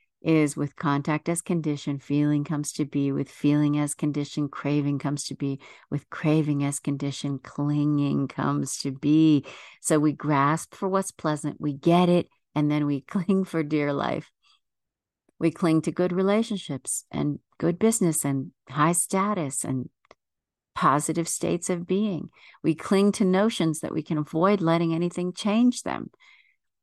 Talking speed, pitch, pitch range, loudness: 155 wpm, 150 Hz, 145-175 Hz, -25 LUFS